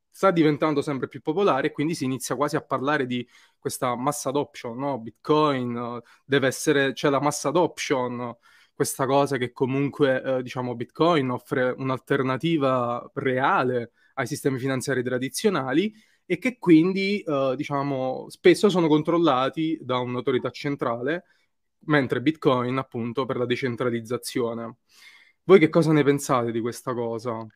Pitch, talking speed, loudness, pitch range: 135 Hz, 140 wpm, -24 LUFS, 125-150 Hz